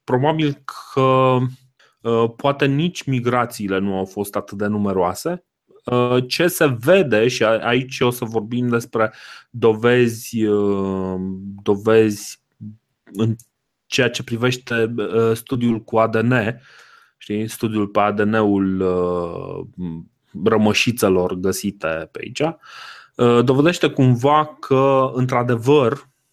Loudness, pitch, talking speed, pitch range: -19 LUFS, 115 Hz, 105 wpm, 105-130 Hz